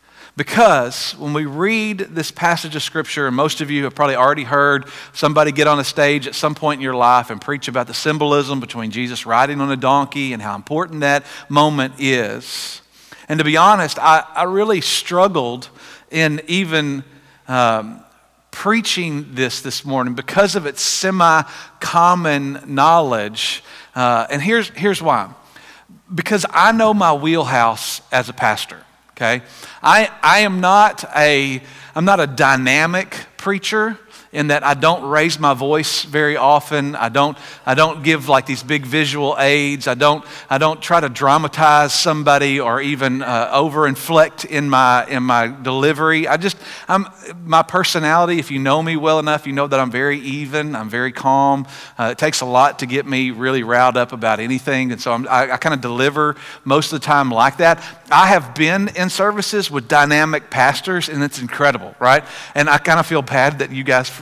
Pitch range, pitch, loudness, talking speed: 135-160 Hz, 145 Hz, -16 LUFS, 180 wpm